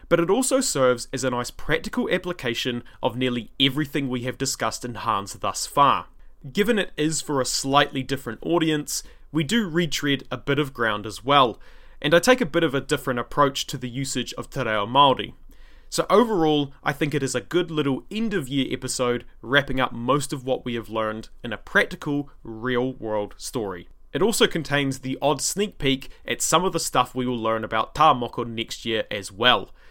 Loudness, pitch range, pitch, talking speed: -23 LUFS, 125-155 Hz, 135 Hz, 195 wpm